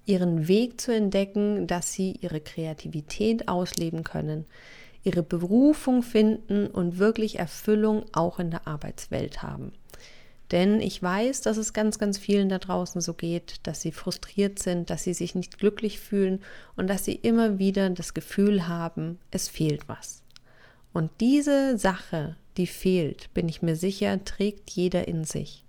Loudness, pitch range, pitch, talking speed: -27 LUFS, 170-210 Hz, 190 Hz, 155 wpm